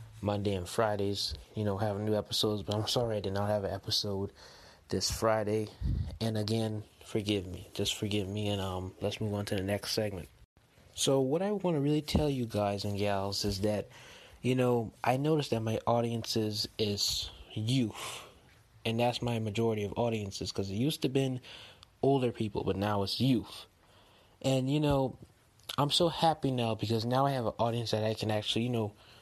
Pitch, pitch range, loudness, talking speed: 110 Hz, 100-120 Hz, -32 LUFS, 195 wpm